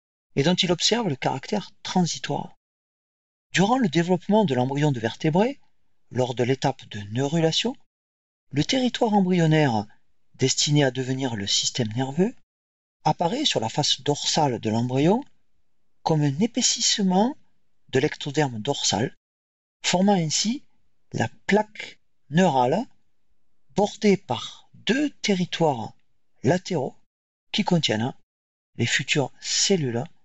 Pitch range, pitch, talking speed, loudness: 120-190 Hz, 150 Hz, 110 wpm, -23 LUFS